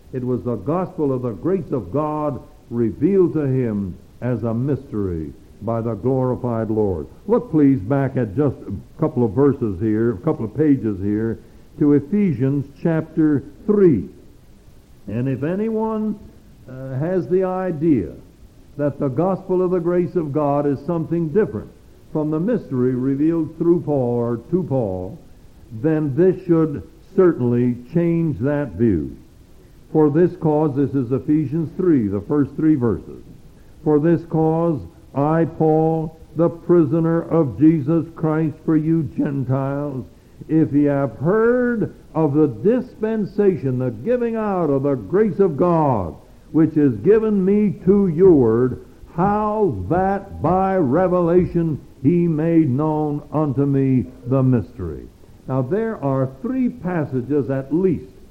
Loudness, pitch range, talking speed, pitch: -19 LUFS, 125-170 Hz, 140 wpm, 150 Hz